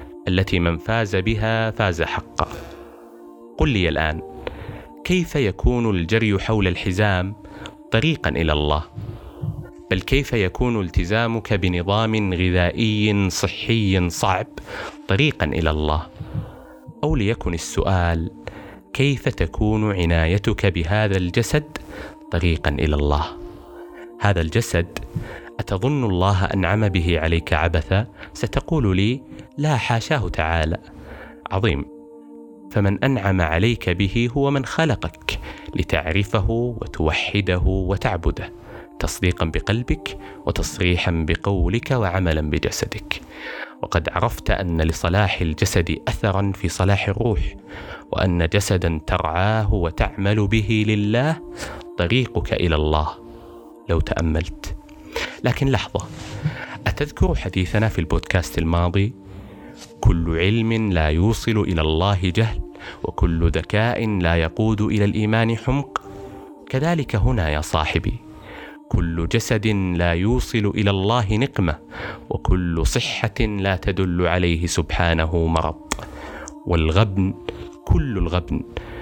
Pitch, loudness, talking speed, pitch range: 100 Hz, -21 LUFS, 100 wpm, 85-110 Hz